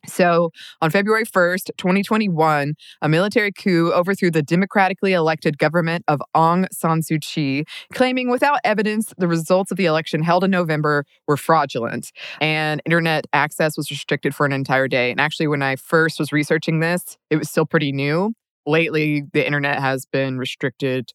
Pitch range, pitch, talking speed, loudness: 150-180 Hz, 160 Hz, 165 wpm, -19 LUFS